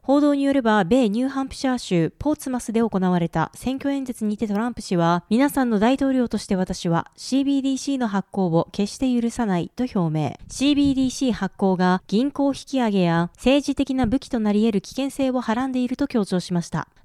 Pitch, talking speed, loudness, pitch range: 235 Hz, 390 characters per minute, -22 LUFS, 190-265 Hz